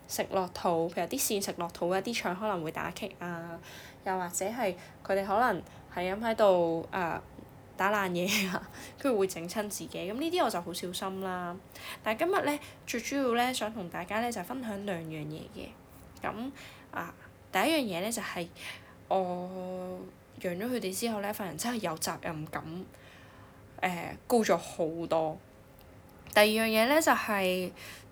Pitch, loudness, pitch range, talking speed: 190 Hz, -32 LUFS, 175-220 Hz, 245 characters per minute